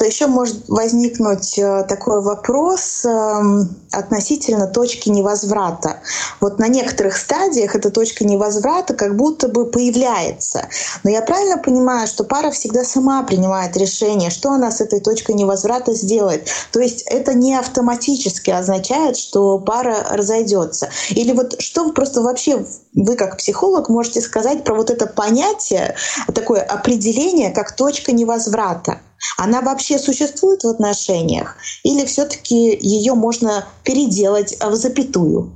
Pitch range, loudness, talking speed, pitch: 205-265 Hz, -16 LUFS, 130 wpm, 230 Hz